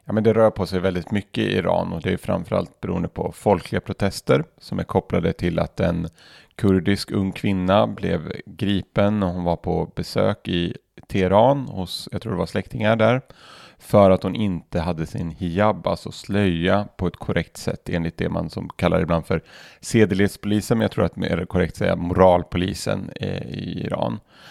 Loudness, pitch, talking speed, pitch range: -22 LUFS, 95 Hz, 185 wpm, 90-105 Hz